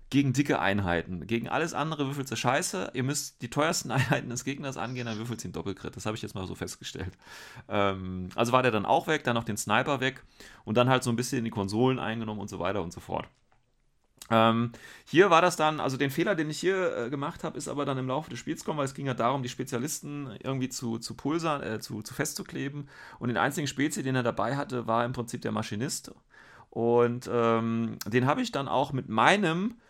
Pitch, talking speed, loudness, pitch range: 125 Hz, 235 wpm, -29 LUFS, 115-140 Hz